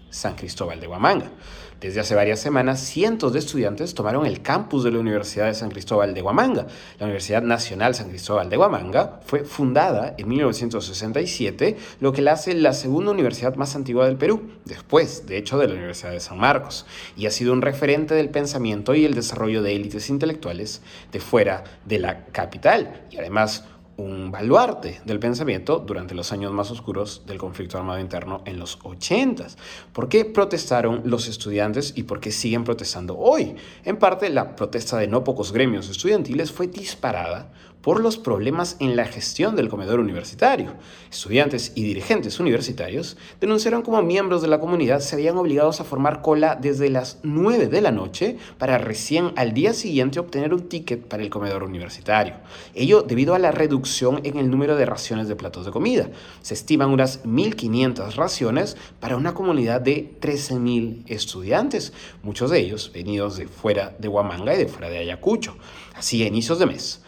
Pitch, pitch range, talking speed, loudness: 120 Hz, 105-145 Hz, 175 wpm, -22 LUFS